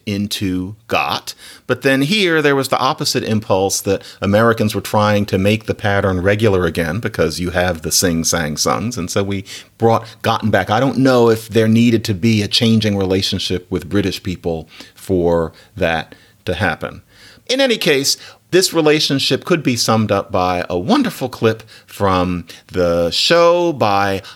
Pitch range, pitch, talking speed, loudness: 95-120 Hz, 105 Hz, 165 wpm, -16 LUFS